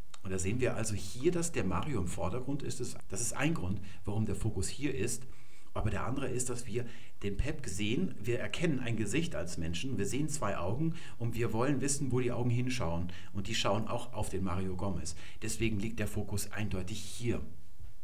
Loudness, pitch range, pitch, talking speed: -36 LUFS, 95-125 Hz, 110 Hz, 205 wpm